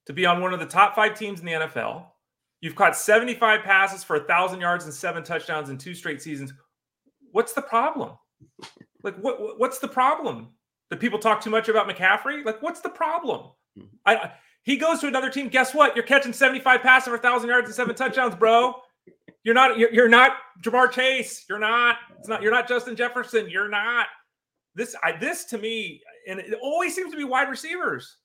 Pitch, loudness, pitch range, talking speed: 235 Hz, -22 LUFS, 195-260 Hz, 205 wpm